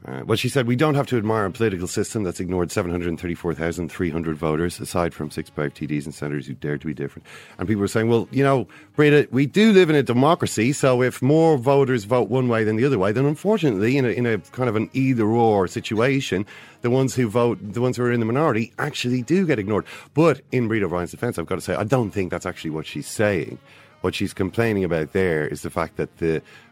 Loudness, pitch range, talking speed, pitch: -22 LUFS, 85-130 Hz, 240 wpm, 110 Hz